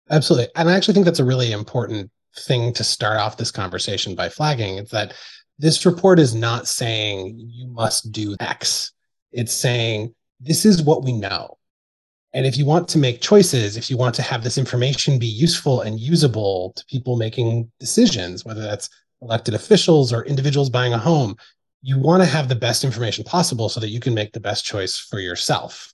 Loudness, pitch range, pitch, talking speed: -19 LUFS, 110-145 Hz, 120 Hz, 195 wpm